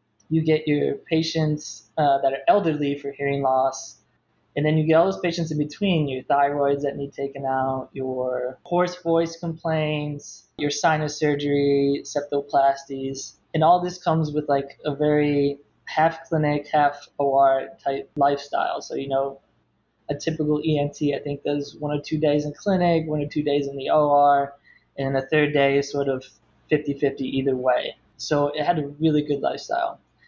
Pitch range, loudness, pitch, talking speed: 140-155 Hz, -23 LUFS, 145 Hz, 175 wpm